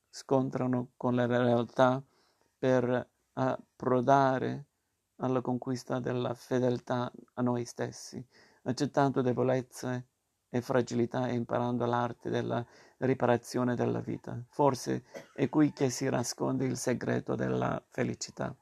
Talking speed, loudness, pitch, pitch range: 110 wpm, -31 LUFS, 125 Hz, 120-130 Hz